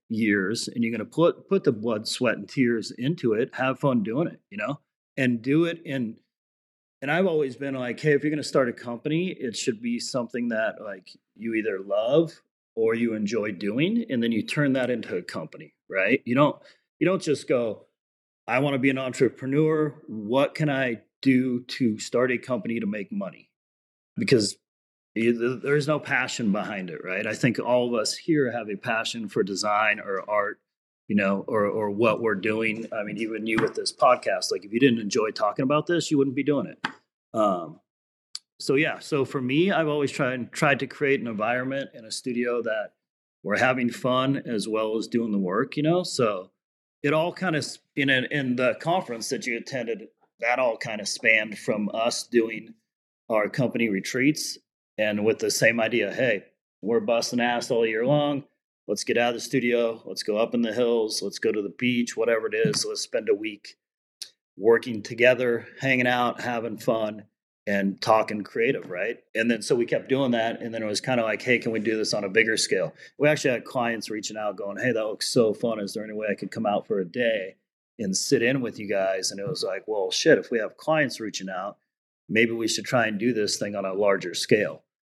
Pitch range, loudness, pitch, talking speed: 110-145 Hz, -25 LUFS, 120 Hz, 215 wpm